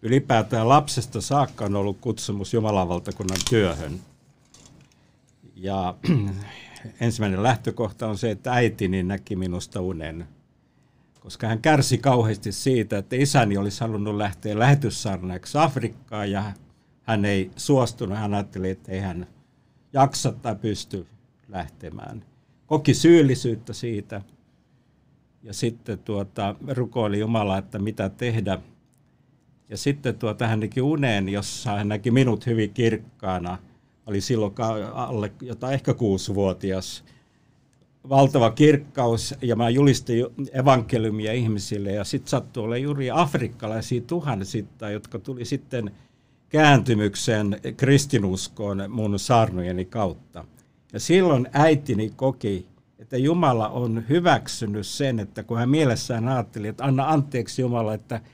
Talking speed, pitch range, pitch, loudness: 115 wpm, 100-130 Hz, 115 Hz, -23 LUFS